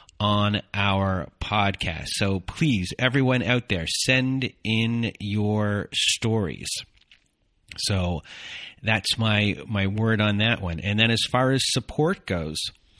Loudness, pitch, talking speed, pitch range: -24 LUFS, 105 Hz, 125 wpm, 95-115 Hz